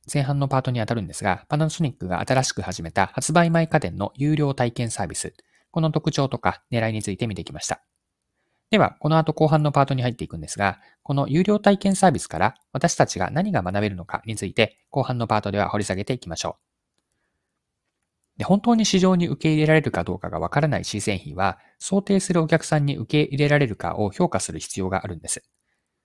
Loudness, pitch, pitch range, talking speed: -23 LUFS, 130 Hz, 100-155 Hz, 440 characters per minute